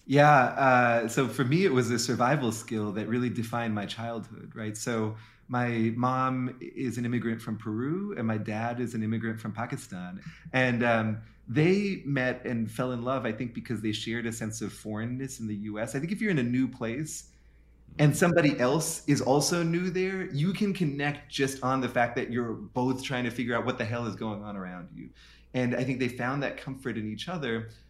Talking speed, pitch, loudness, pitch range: 215 wpm, 120 Hz, -29 LUFS, 110-135 Hz